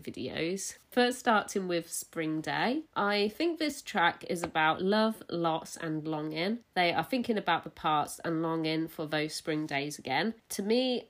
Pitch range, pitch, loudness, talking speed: 160-220 Hz, 170 Hz, -31 LUFS, 170 wpm